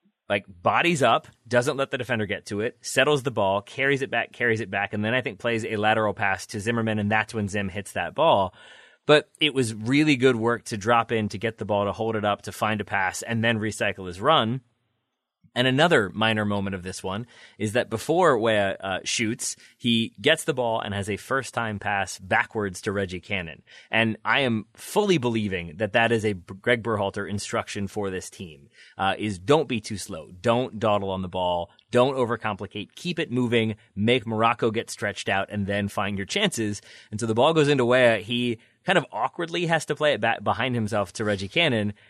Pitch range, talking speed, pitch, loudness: 100-125 Hz, 215 wpm, 110 Hz, -24 LUFS